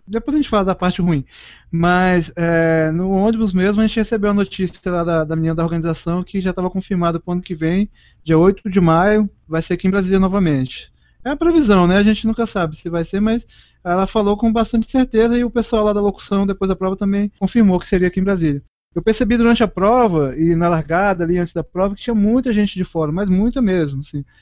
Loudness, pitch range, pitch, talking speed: -17 LUFS, 170-215 Hz, 190 Hz, 240 wpm